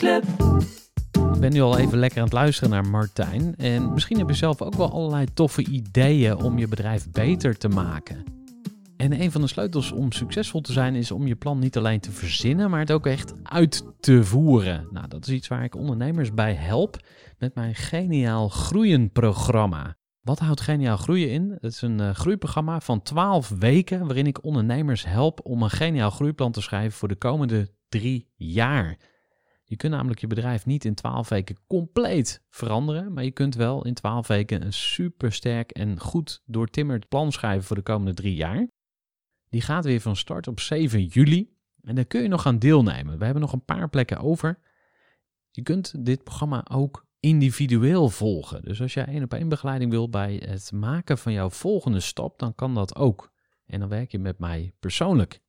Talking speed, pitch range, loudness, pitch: 190 wpm, 110-150 Hz, -24 LUFS, 125 Hz